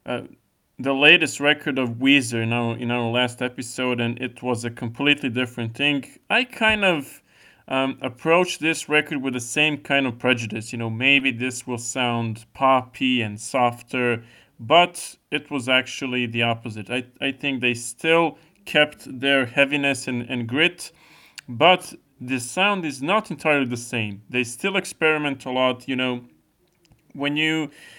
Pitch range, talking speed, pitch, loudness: 120-150 Hz, 160 wpm, 130 Hz, -21 LUFS